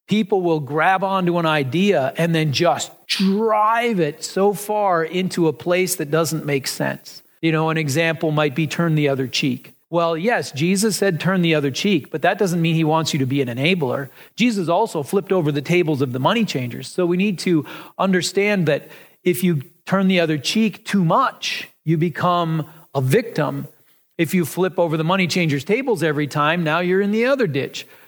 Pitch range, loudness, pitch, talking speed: 155-190 Hz, -19 LUFS, 170 Hz, 200 wpm